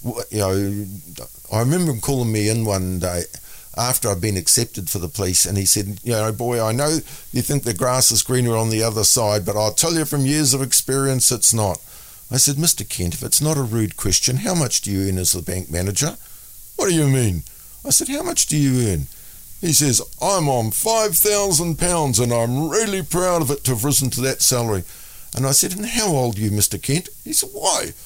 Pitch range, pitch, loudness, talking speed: 105-145 Hz, 120 Hz, -18 LUFS, 225 wpm